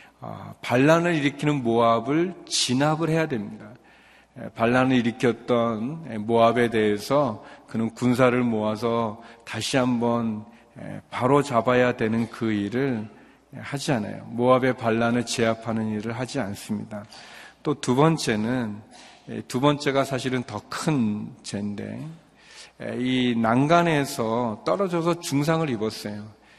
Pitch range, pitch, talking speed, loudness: 115-140 Hz, 120 Hz, 245 characters per minute, -24 LUFS